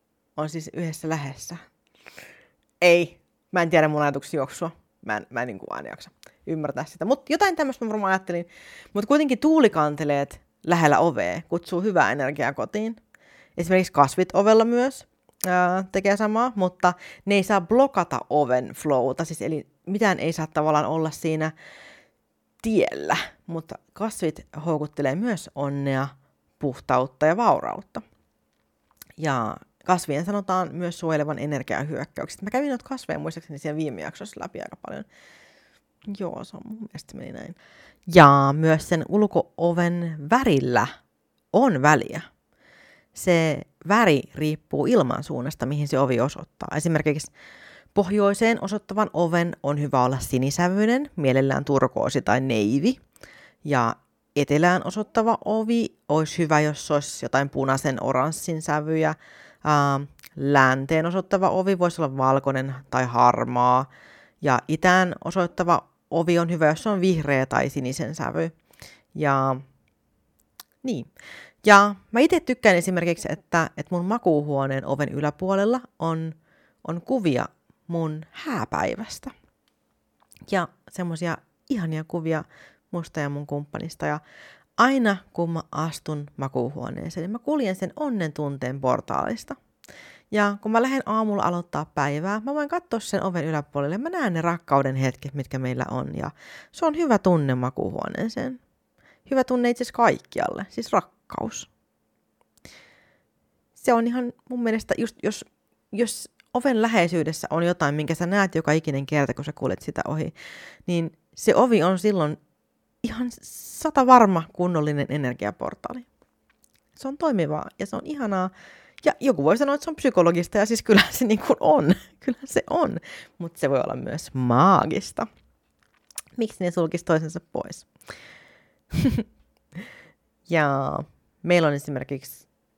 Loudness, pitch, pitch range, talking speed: -23 LUFS, 170 Hz, 145-210 Hz, 135 wpm